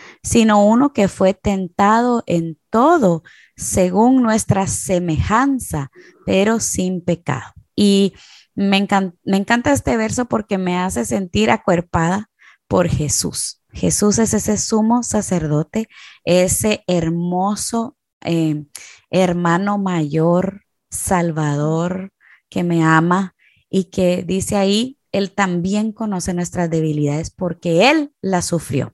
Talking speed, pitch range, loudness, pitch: 110 wpm, 170-210 Hz, -17 LUFS, 190 Hz